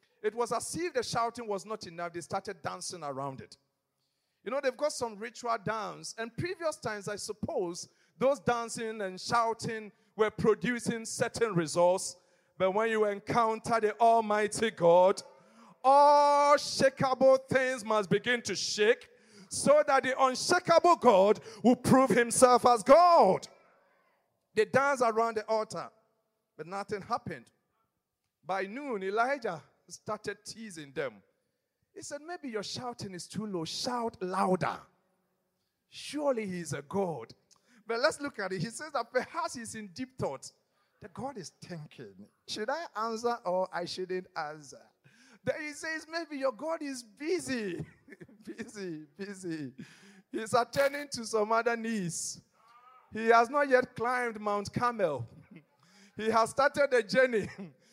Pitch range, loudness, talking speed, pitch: 190-255 Hz, -30 LUFS, 145 wpm, 220 Hz